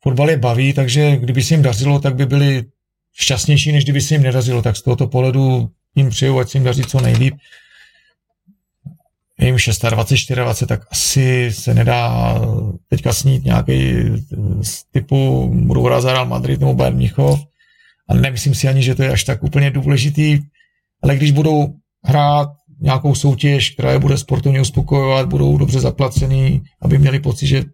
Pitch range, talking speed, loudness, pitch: 115-140 Hz, 165 wpm, -15 LUFS, 135 Hz